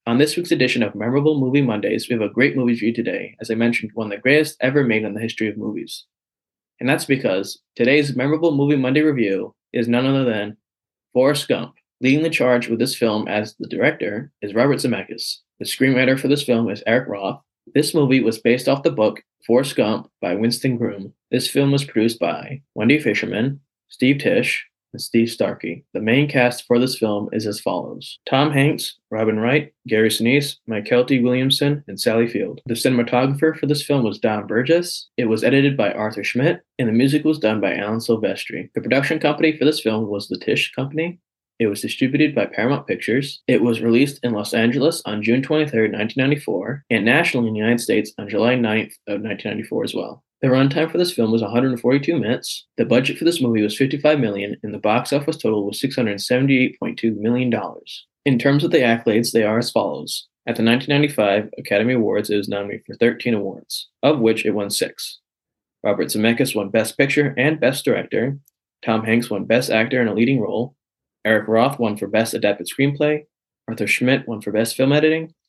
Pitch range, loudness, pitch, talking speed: 110-140 Hz, -19 LUFS, 125 Hz, 200 wpm